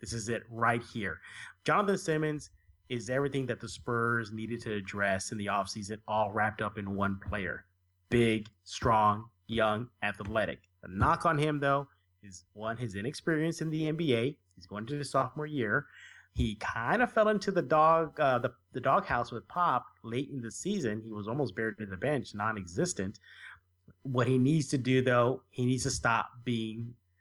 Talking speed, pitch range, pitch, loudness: 180 wpm, 105-135 Hz, 115 Hz, -31 LUFS